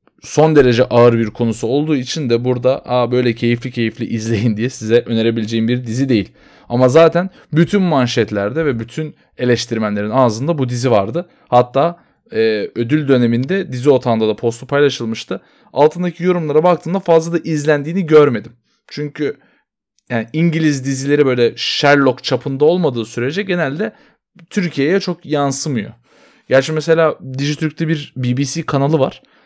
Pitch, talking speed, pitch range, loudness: 135 Hz, 135 wpm, 120-155 Hz, -16 LUFS